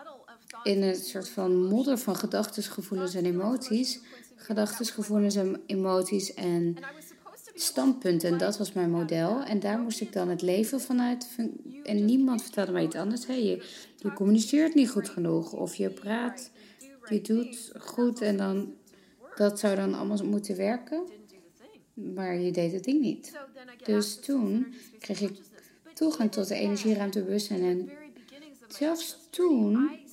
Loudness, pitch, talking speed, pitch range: -29 LUFS, 215 Hz, 145 wpm, 195-255 Hz